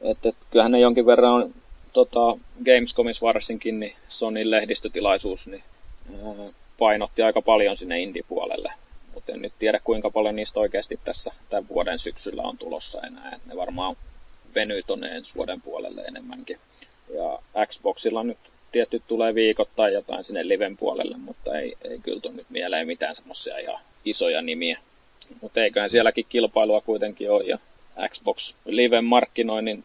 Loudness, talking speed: -24 LUFS, 155 wpm